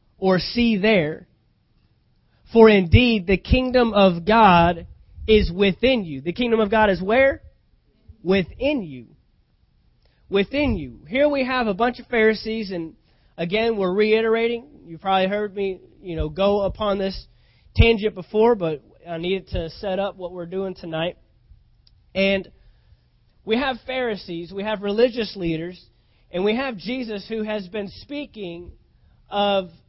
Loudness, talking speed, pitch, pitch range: -21 LUFS, 145 wpm, 200 Hz, 180-225 Hz